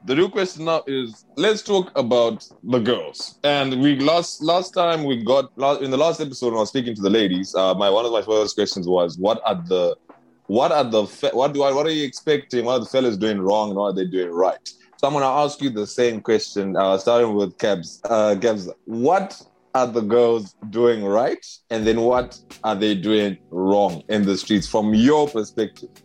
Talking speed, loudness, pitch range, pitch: 220 wpm, -20 LUFS, 105-140 Hz, 120 Hz